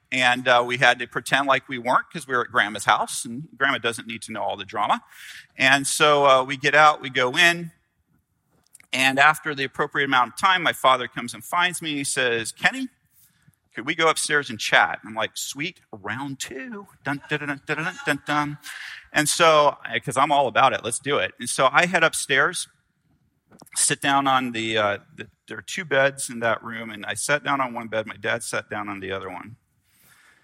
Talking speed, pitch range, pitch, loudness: 220 wpm, 120-150 Hz, 135 Hz, -21 LUFS